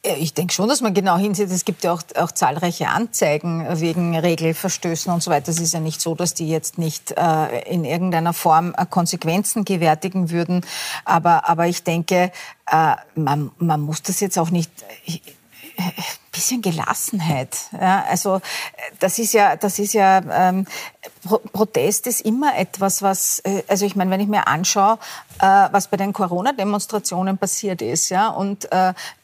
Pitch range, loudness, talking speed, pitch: 170-200 Hz, -19 LUFS, 170 wpm, 180 Hz